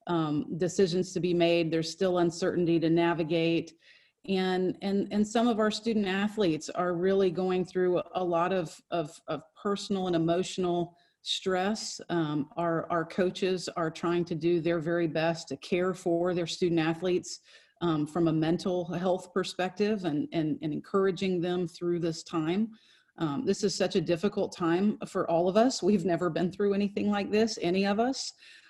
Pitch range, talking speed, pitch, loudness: 170-195 Hz, 175 wpm, 180 Hz, -29 LUFS